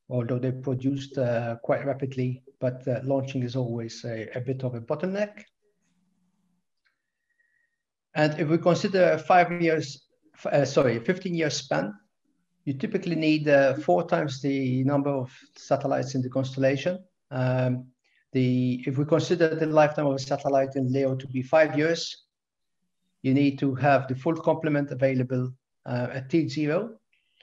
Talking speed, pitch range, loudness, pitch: 150 wpm, 130-170 Hz, -26 LUFS, 140 Hz